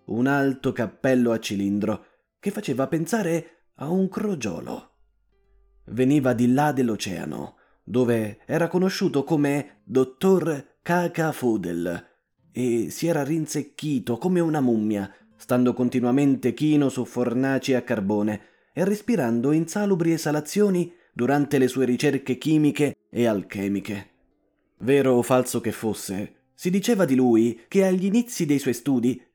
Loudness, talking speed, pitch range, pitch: -23 LUFS, 125 wpm, 120-165 Hz, 135 Hz